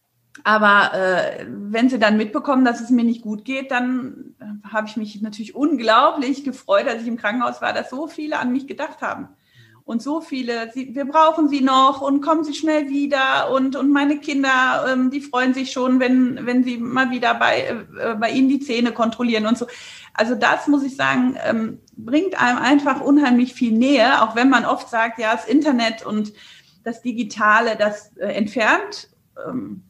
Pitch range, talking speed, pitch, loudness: 225-280 Hz, 190 wpm, 255 Hz, -19 LUFS